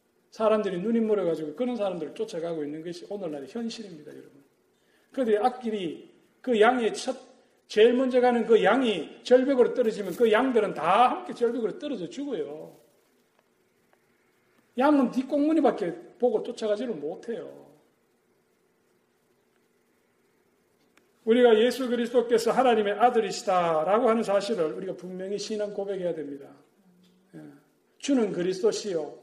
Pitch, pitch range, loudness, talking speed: 225 Hz, 195-245 Hz, -26 LUFS, 310 characters per minute